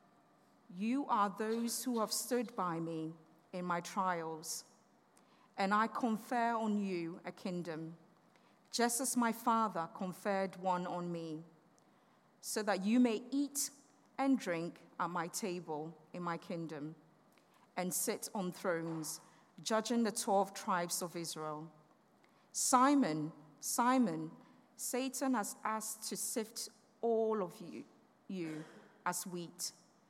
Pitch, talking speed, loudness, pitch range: 195 Hz, 125 wpm, -37 LUFS, 170-230 Hz